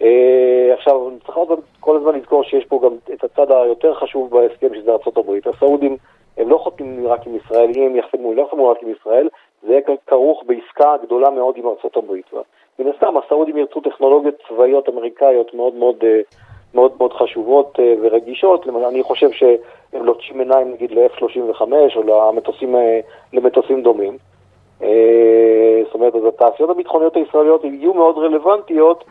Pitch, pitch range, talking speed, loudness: 135 Hz, 120-180 Hz, 155 wpm, -15 LUFS